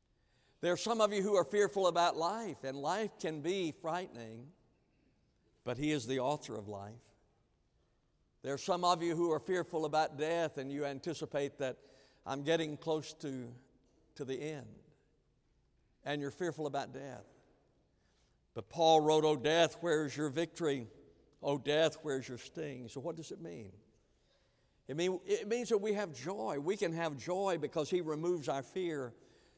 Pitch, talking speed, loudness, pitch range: 155 Hz, 170 wpm, -36 LUFS, 135-170 Hz